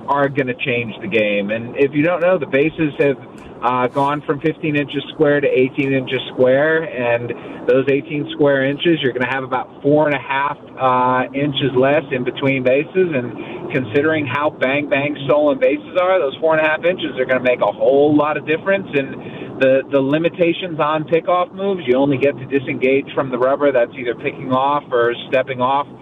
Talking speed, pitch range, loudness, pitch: 205 wpm, 130-155 Hz, -17 LUFS, 140 Hz